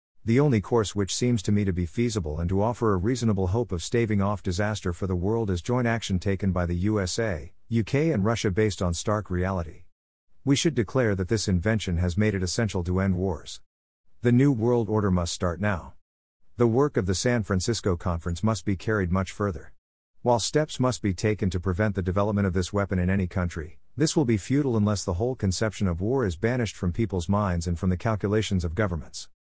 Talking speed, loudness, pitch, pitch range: 215 wpm, -26 LUFS, 100 Hz, 90-115 Hz